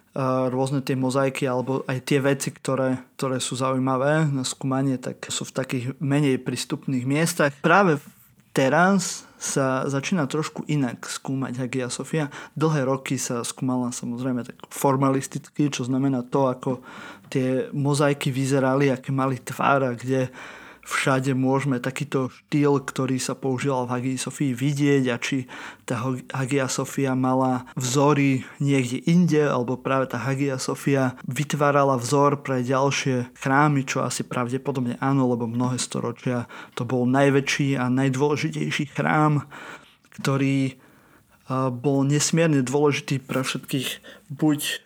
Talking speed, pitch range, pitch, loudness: 130 wpm, 130-145 Hz, 135 Hz, -24 LUFS